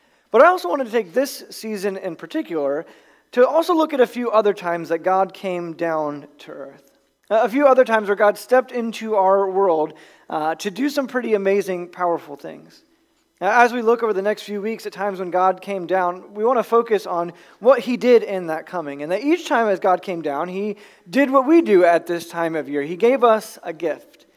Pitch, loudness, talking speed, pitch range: 205 Hz, -20 LUFS, 225 wpm, 175-245 Hz